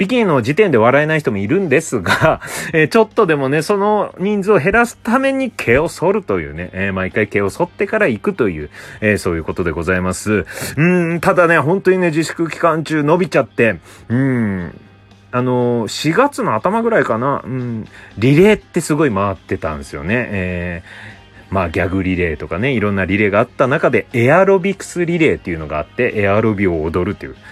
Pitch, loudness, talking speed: 125 Hz, -16 LUFS, 400 characters per minute